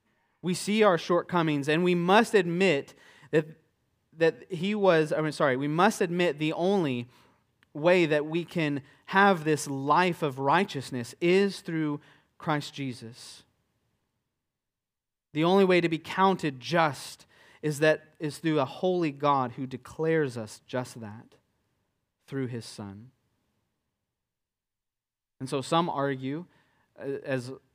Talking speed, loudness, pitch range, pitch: 130 wpm, -27 LUFS, 130-170 Hz, 150 Hz